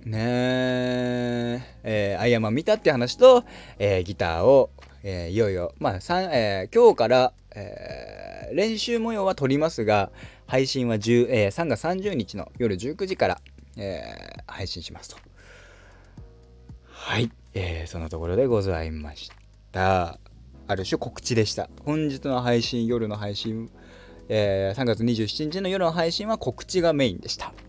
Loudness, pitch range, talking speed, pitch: -24 LUFS, 95-135 Hz, 260 characters per minute, 115 Hz